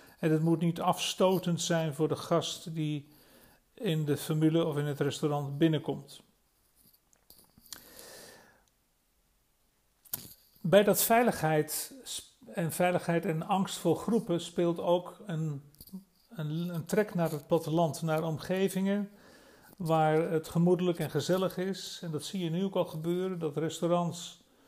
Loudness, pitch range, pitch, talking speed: -31 LUFS, 155-185 Hz, 170 Hz, 130 wpm